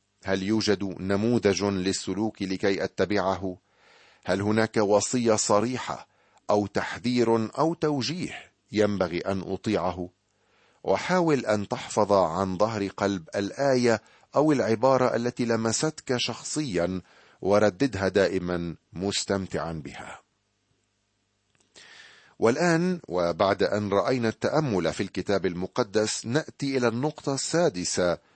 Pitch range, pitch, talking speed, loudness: 95-120 Hz, 105 Hz, 95 wpm, -26 LUFS